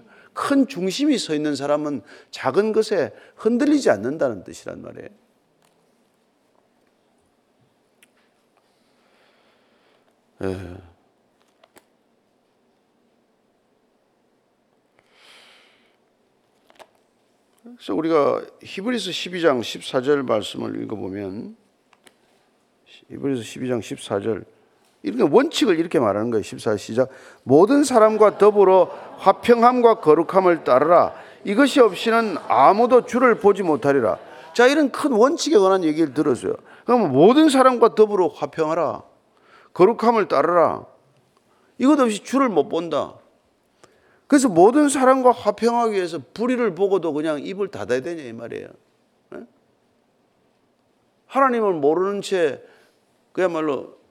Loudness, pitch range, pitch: -19 LUFS, 160-255 Hz, 210 Hz